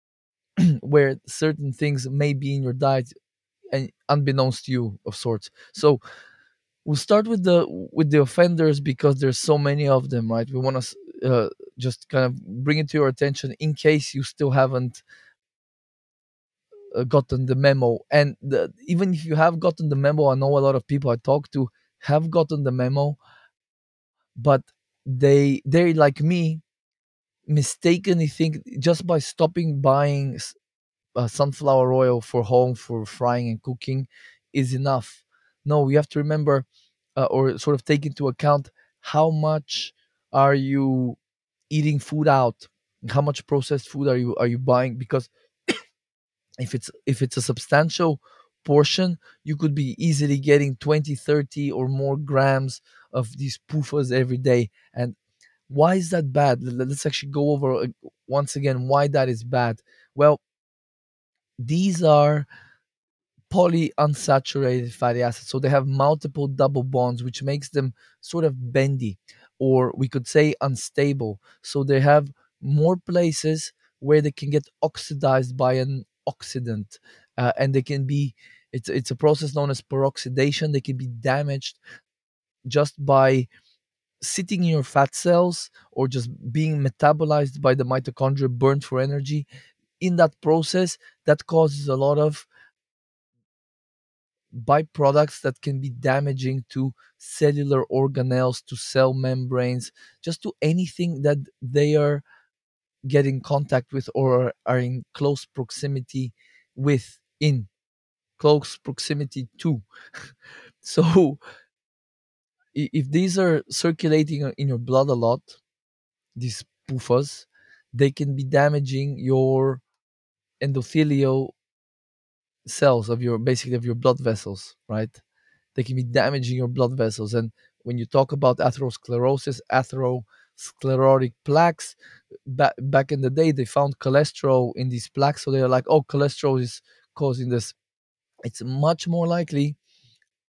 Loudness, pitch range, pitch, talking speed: -22 LUFS, 130-150 Hz, 140 Hz, 140 wpm